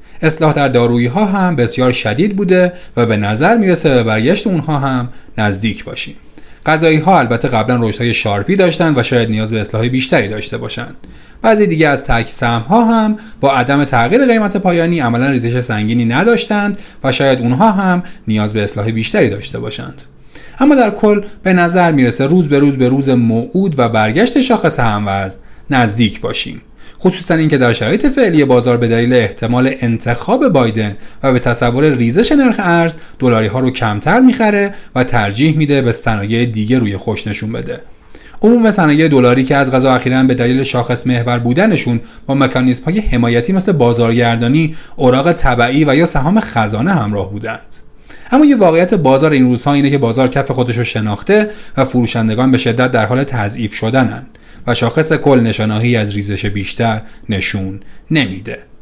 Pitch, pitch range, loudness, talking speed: 130 Hz, 115-165 Hz, -12 LUFS, 170 wpm